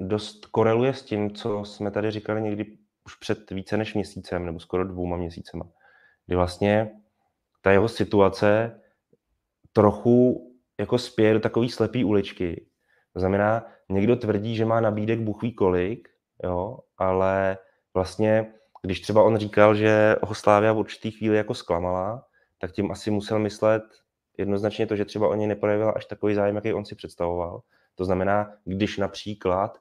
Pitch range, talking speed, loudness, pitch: 95-110 Hz, 155 wpm, -24 LUFS, 105 Hz